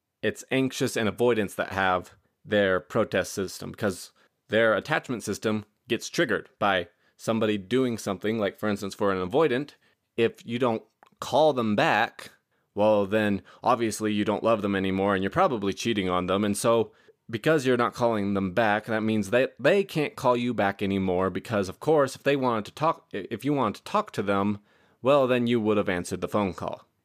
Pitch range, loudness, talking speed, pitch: 100-120 Hz, -26 LUFS, 195 wpm, 110 Hz